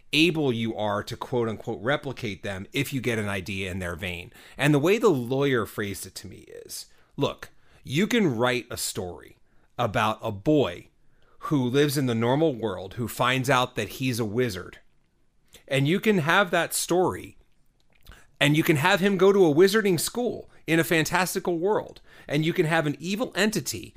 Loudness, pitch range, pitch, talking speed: -25 LUFS, 115-170 Hz, 135 Hz, 190 wpm